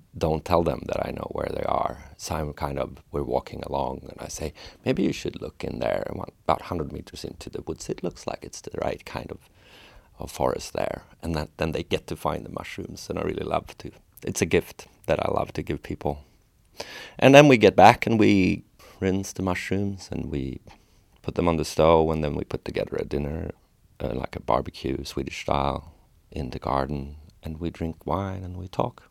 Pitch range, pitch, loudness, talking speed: 70-95 Hz, 80 Hz, -25 LUFS, 220 wpm